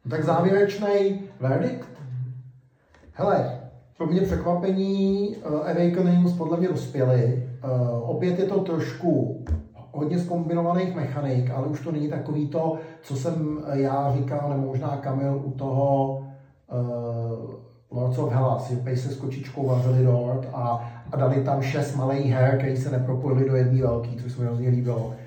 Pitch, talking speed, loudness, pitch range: 135 Hz, 150 wpm, -25 LUFS, 125-160 Hz